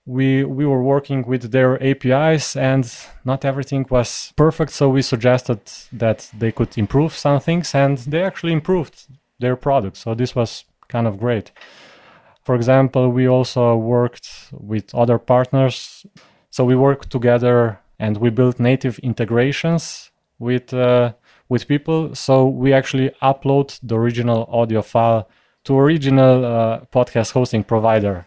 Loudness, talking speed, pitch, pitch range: -18 LUFS, 145 wpm, 125 Hz, 115-135 Hz